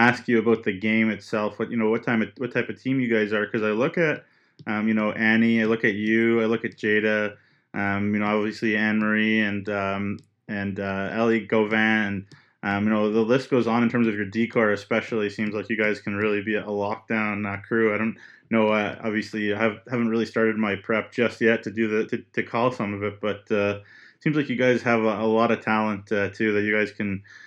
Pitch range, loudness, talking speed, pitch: 105-115 Hz, -24 LUFS, 245 wpm, 110 Hz